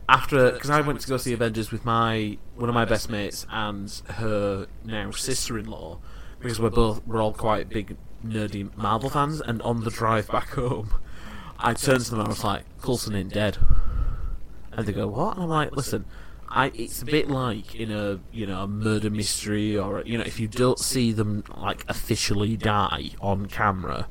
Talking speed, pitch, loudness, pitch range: 195 wpm, 110 Hz, -26 LUFS, 100-120 Hz